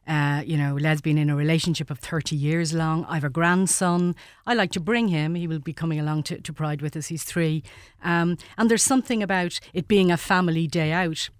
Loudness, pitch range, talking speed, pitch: -24 LUFS, 155-175 Hz, 225 wpm, 165 Hz